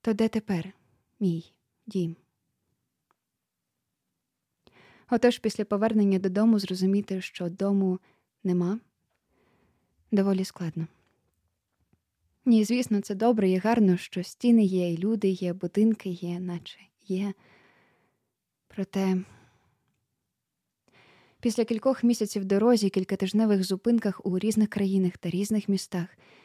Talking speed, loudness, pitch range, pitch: 100 wpm, -27 LUFS, 185-215 Hz, 195 Hz